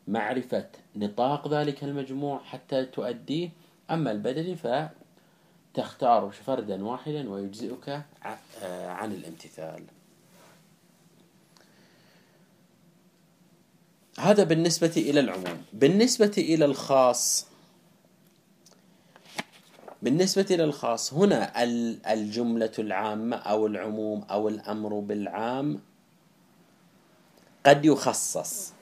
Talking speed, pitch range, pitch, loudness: 70 wpm, 115-180 Hz, 150 Hz, -27 LUFS